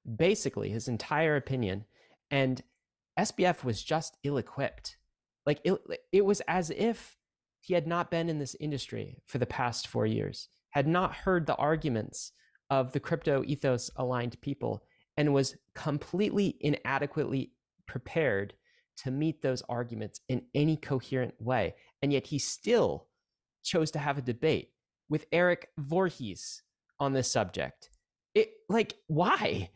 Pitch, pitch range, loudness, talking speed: 145 Hz, 125-165 Hz, -31 LUFS, 140 wpm